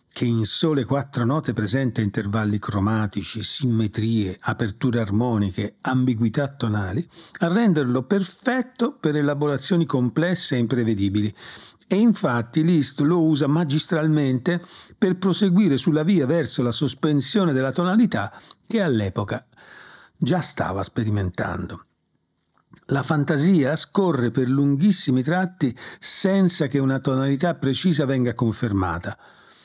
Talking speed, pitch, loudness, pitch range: 110 wpm, 135 Hz, -21 LUFS, 115-170 Hz